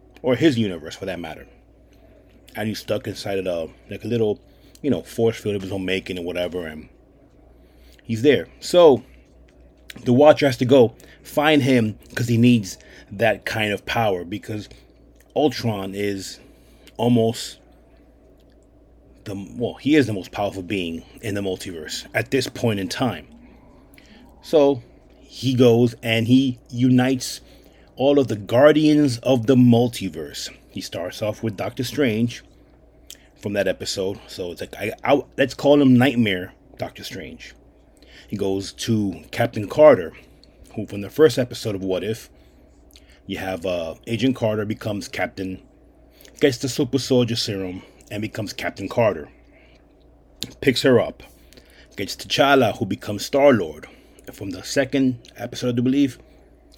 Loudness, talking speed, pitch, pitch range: -21 LUFS, 150 wpm, 110 Hz, 95-130 Hz